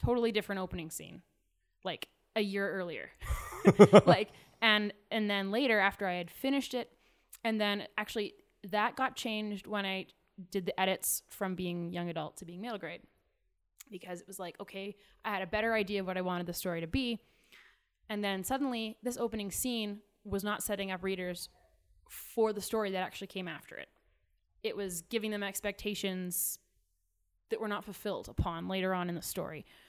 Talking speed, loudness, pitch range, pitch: 180 wpm, -33 LUFS, 185-215 Hz, 200 Hz